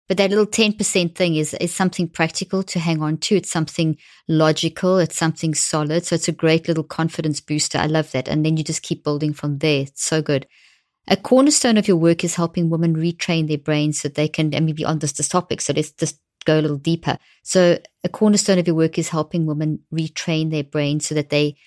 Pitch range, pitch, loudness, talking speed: 150-175 Hz, 160 Hz, -20 LUFS, 235 wpm